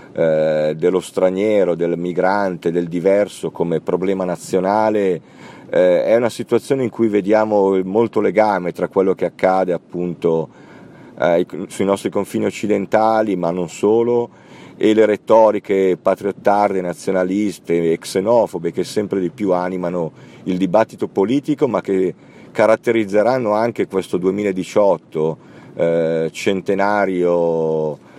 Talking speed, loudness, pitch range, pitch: 110 wpm, -18 LUFS, 85-105 Hz, 95 Hz